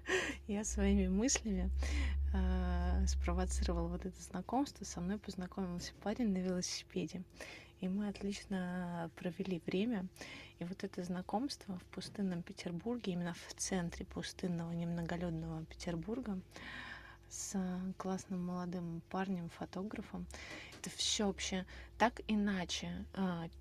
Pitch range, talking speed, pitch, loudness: 170-200 Hz, 105 wpm, 185 Hz, -40 LUFS